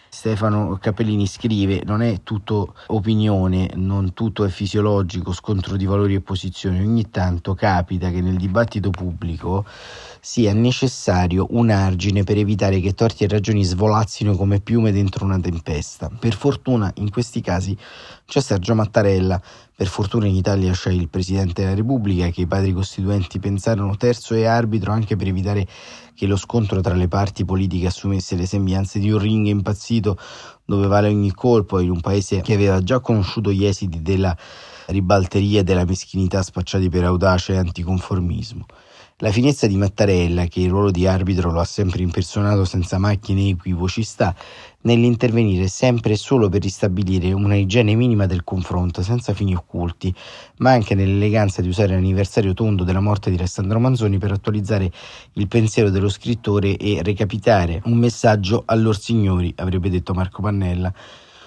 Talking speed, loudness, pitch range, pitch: 160 wpm, -19 LUFS, 95-110 Hz, 100 Hz